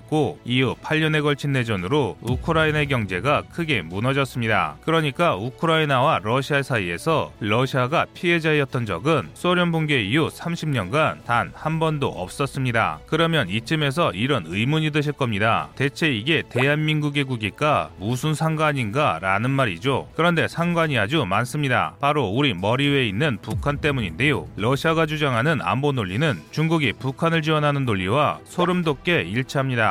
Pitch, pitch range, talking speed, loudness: 140 Hz, 120-155 Hz, 355 characters per minute, -22 LUFS